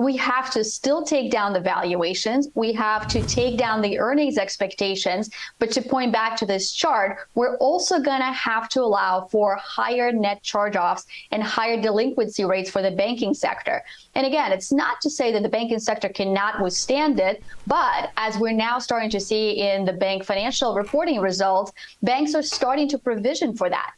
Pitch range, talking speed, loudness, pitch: 200-260 Hz, 190 wpm, -22 LUFS, 225 Hz